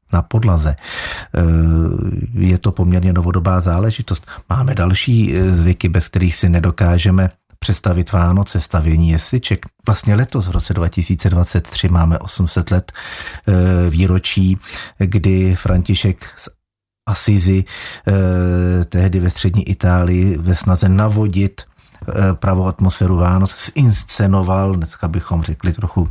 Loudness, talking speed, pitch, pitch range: -16 LUFS, 105 wpm, 95 Hz, 90-100 Hz